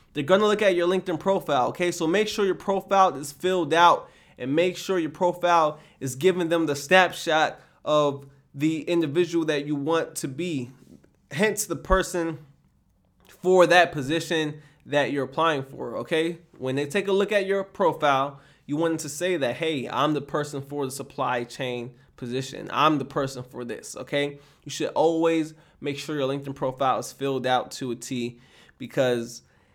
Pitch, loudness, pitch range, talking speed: 155 Hz, -25 LUFS, 135-175 Hz, 180 wpm